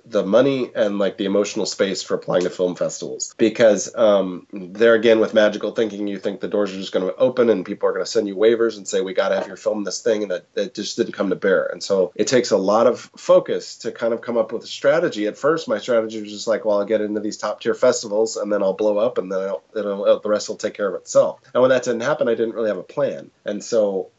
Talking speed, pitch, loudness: 290 wpm, 120 Hz, -20 LUFS